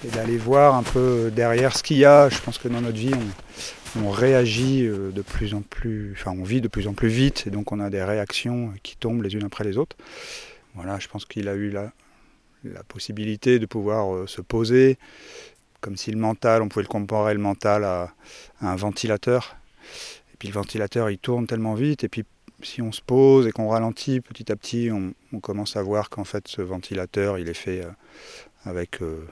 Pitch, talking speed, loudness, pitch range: 110 Hz, 220 wpm, -23 LUFS, 100-120 Hz